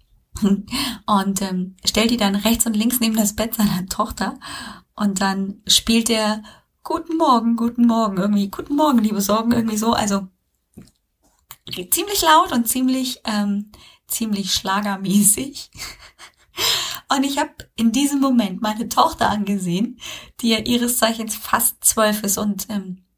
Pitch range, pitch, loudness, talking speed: 200-245 Hz, 220 Hz, -19 LUFS, 140 wpm